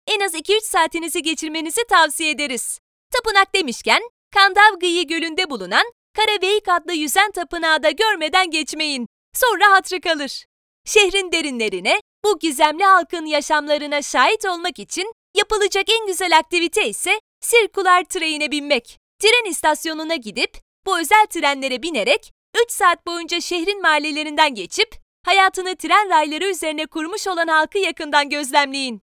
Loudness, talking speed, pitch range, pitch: -18 LUFS, 125 wpm, 310-395 Hz, 350 Hz